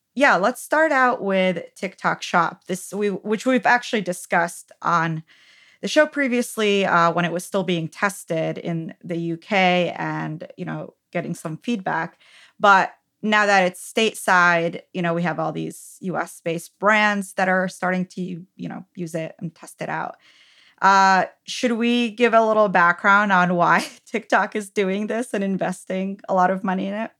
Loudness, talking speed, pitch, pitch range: -21 LUFS, 175 wpm, 185 Hz, 170-210 Hz